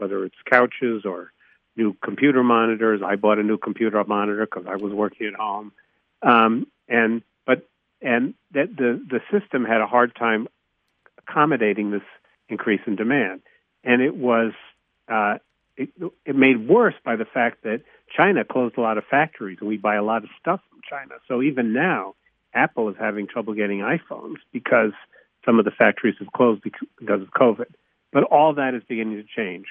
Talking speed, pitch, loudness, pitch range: 180 wpm, 115 Hz, -21 LUFS, 105-125 Hz